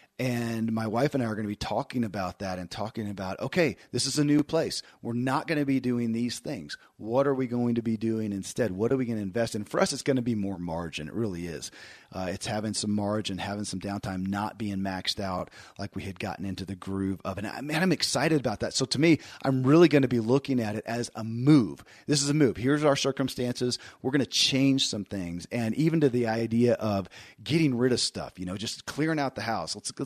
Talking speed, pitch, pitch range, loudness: 260 wpm, 115 Hz, 100-135 Hz, -28 LUFS